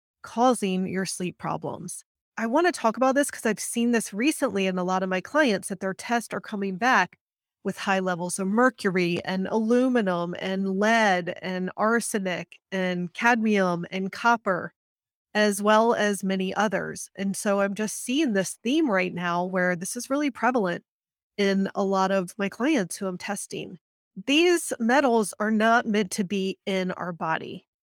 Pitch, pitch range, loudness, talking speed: 200 Hz, 185-230 Hz, -25 LUFS, 175 wpm